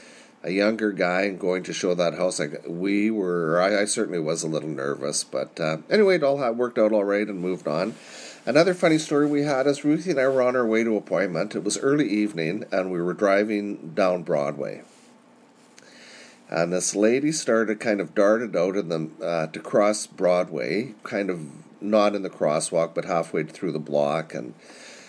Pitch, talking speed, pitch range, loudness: 105 Hz, 195 wpm, 90-120 Hz, -24 LUFS